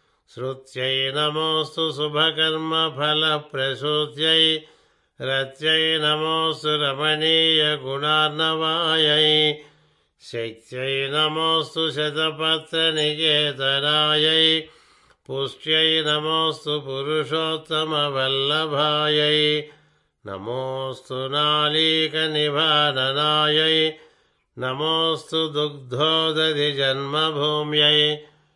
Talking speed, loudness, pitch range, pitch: 35 wpm, -20 LUFS, 145-160 Hz, 150 Hz